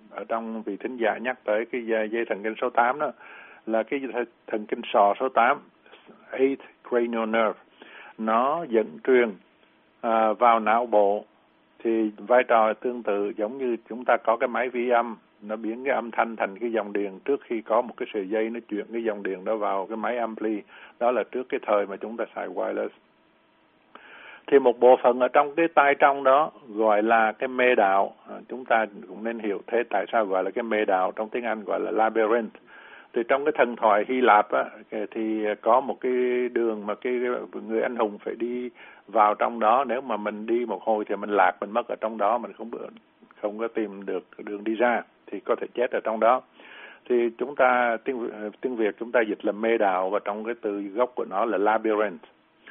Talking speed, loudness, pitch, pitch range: 215 wpm, -25 LUFS, 115 Hz, 105-120 Hz